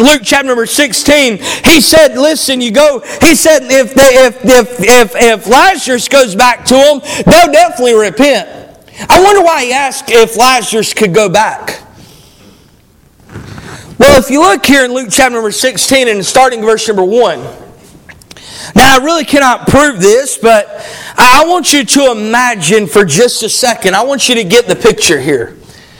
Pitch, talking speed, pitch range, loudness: 260 Hz, 170 wpm, 230-290 Hz, -7 LUFS